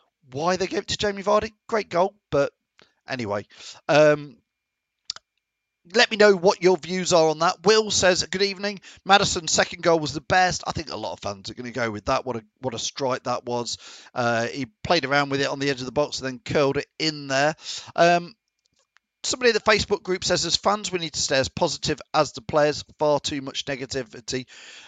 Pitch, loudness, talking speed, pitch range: 155 Hz, -23 LUFS, 215 wpm, 130-185 Hz